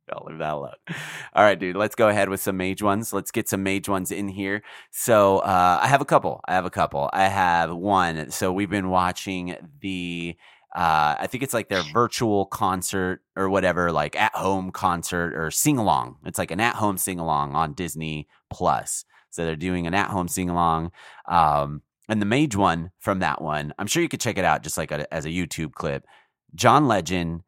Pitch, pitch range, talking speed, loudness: 95 Hz, 85-100 Hz, 200 wpm, -23 LUFS